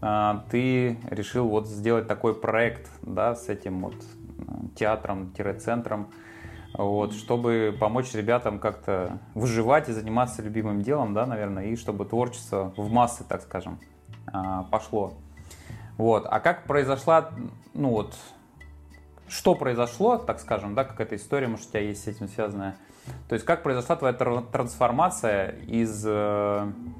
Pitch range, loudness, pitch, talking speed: 100-120 Hz, -27 LUFS, 110 Hz, 130 wpm